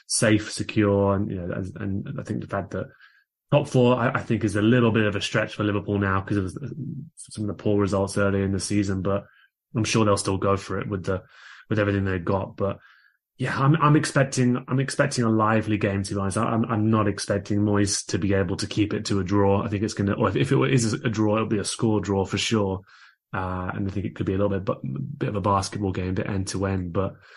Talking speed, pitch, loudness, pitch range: 260 wpm, 105 Hz, -24 LUFS, 100-110 Hz